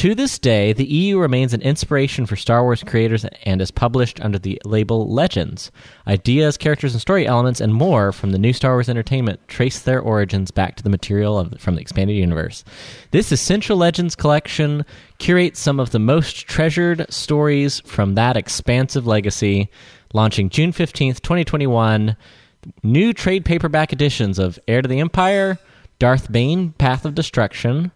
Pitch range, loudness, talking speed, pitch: 110-155 Hz, -18 LUFS, 165 wpm, 125 Hz